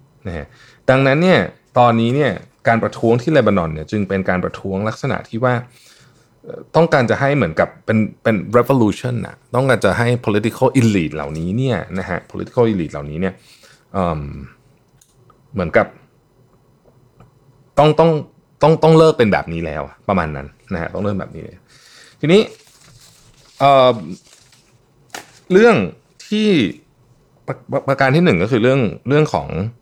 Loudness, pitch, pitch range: -16 LUFS, 125 Hz, 100-140 Hz